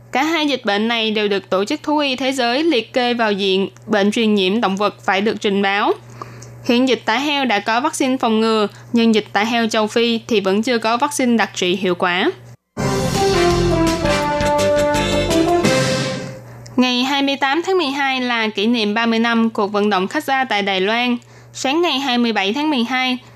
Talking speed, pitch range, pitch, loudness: 185 wpm, 200-265 Hz, 230 Hz, -17 LUFS